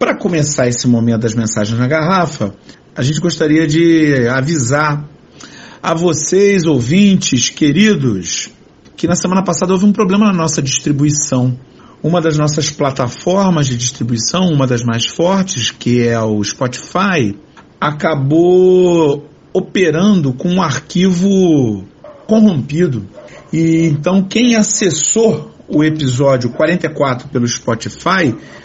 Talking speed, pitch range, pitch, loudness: 115 wpm, 130-180 Hz, 155 Hz, -13 LUFS